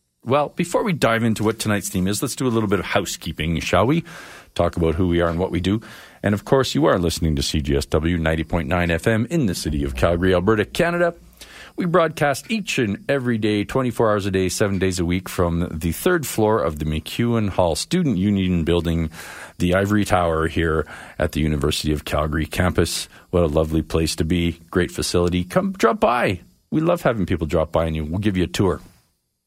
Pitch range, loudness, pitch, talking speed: 80-110 Hz, -21 LUFS, 90 Hz, 210 wpm